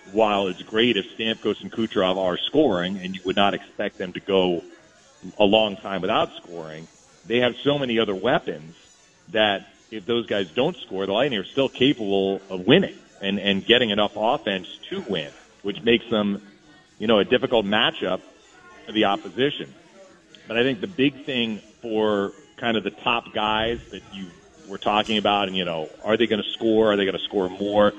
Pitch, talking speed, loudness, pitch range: 105 Hz, 195 wpm, -23 LUFS, 95-115 Hz